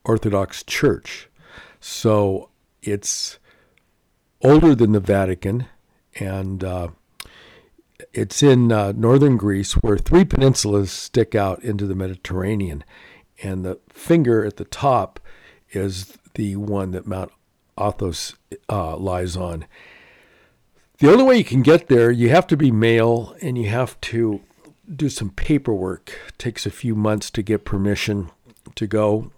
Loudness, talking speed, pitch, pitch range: -19 LUFS, 135 wpm, 105 Hz, 95-120 Hz